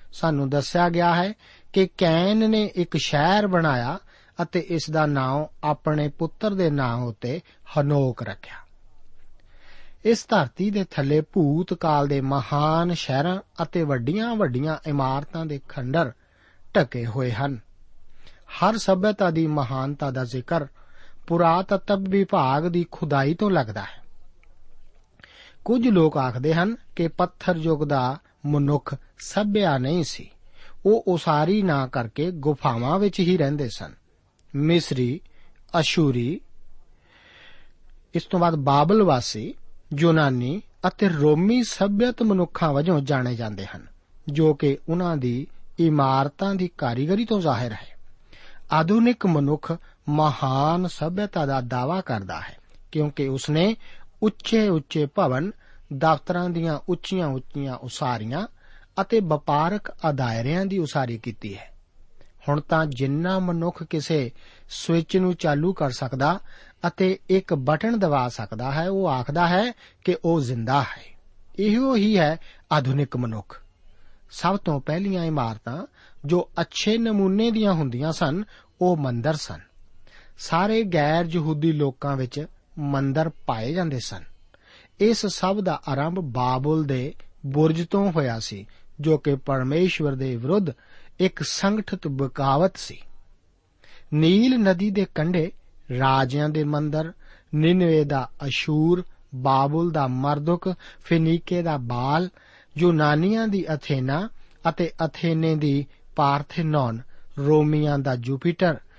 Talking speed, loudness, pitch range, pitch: 120 wpm, -23 LUFS, 135-180 Hz, 155 Hz